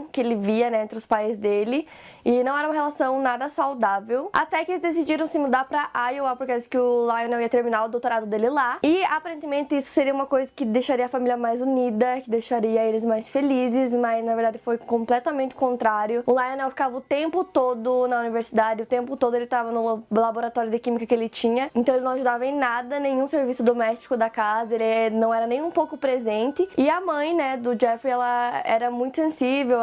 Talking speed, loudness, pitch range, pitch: 215 wpm, -23 LUFS, 230-275 Hz, 250 Hz